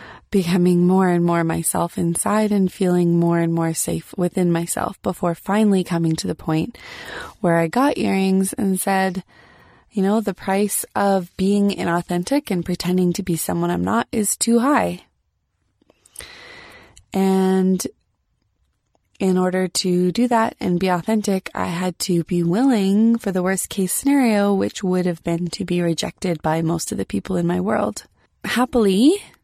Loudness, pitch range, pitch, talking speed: -20 LUFS, 170-200 Hz, 185 Hz, 160 wpm